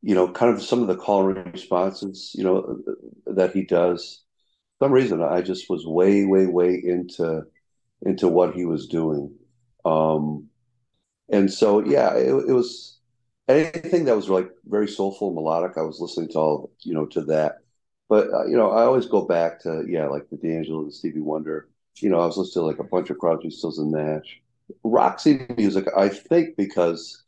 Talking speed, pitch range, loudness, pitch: 195 wpm, 80-100 Hz, -22 LUFS, 90 Hz